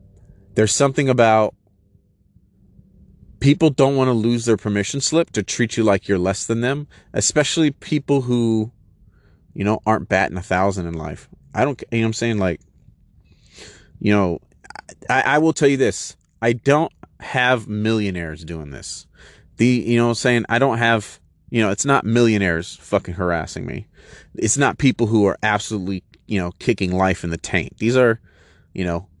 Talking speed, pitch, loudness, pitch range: 175 wpm, 105 Hz, -19 LUFS, 95-120 Hz